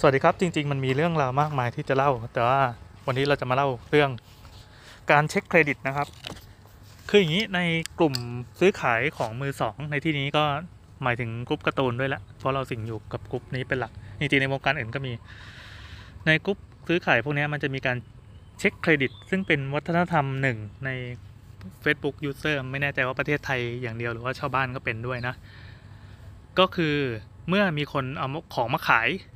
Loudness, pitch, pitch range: -26 LUFS, 135 Hz, 115-150 Hz